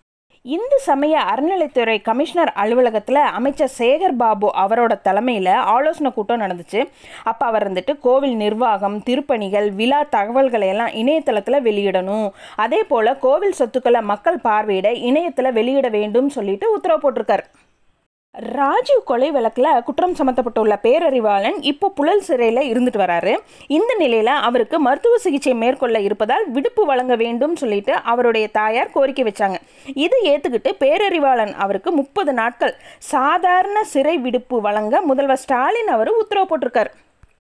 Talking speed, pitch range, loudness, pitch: 120 wpm, 220-300 Hz, -17 LUFS, 255 Hz